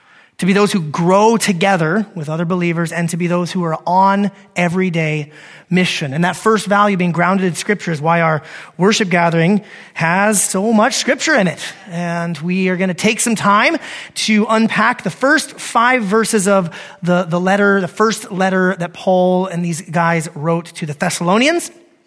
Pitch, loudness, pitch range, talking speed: 185 Hz, -15 LUFS, 175-215 Hz, 180 wpm